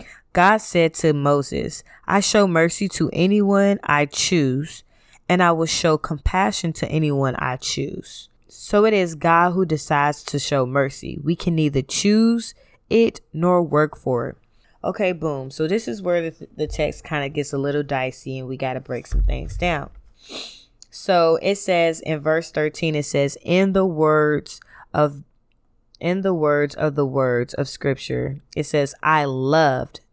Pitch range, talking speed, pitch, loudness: 145-175 Hz, 170 wpm, 155 Hz, -20 LUFS